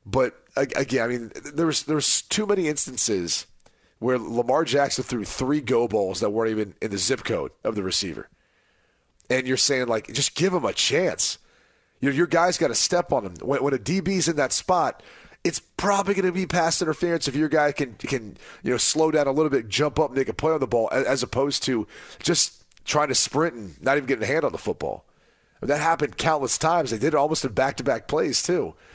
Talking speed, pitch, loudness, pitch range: 225 wpm, 145 Hz, -23 LUFS, 130-165 Hz